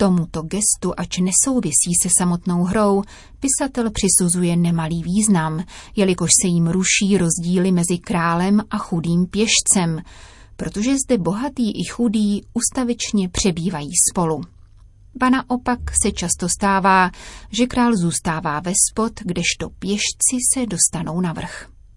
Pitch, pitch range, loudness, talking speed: 185 Hz, 170-220 Hz, -18 LUFS, 125 wpm